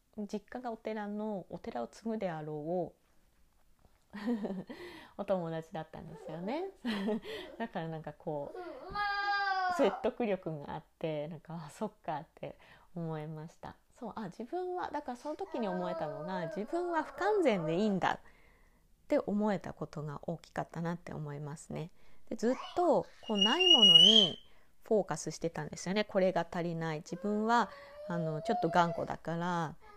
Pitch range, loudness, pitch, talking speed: 160-235 Hz, -32 LUFS, 200 Hz, 305 characters per minute